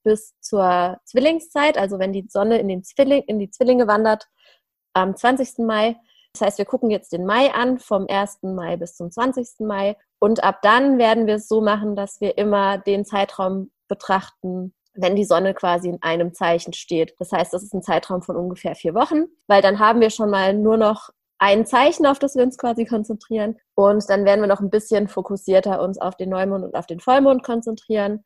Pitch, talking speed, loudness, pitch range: 205 Hz, 205 wpm, -19 LUFS, 190-225 Hz